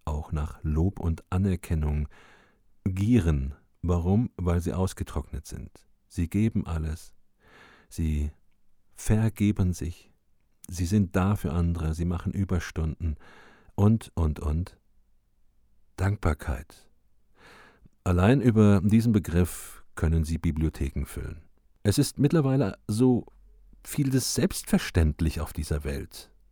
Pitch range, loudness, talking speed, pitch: 80-100 Hz, -27 LUFS, 105 wpm, 90 Hz